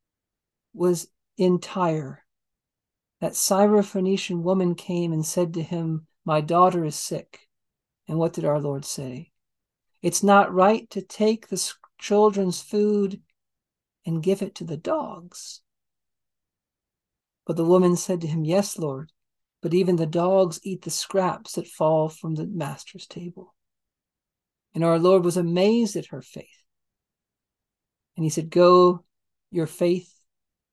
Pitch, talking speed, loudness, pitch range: 175 Hz, 135 wpm, -23 LUFS, 160-190 Hz